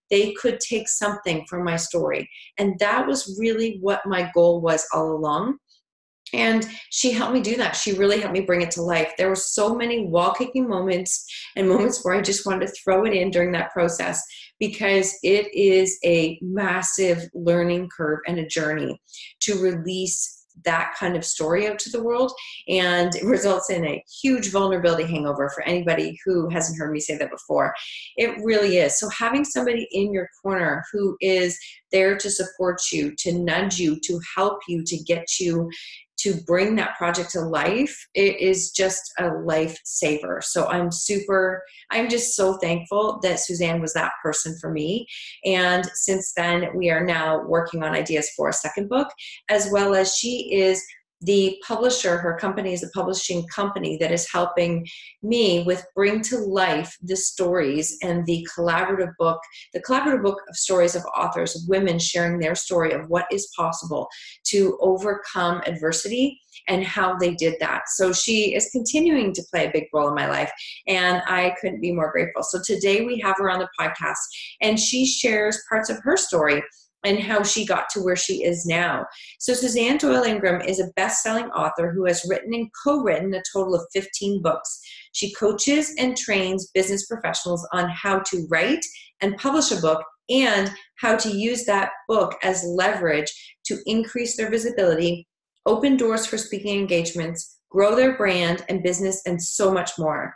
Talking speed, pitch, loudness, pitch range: 180 wpm, 190 Hz, -22 LUFS, 170-210 Hz